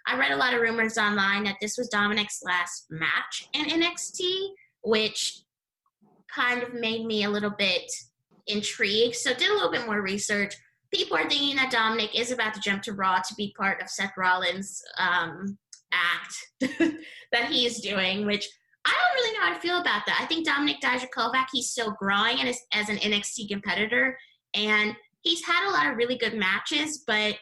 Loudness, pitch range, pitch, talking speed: -25 LUFS, 205-265 Hz, 225 Hz, 185 wpm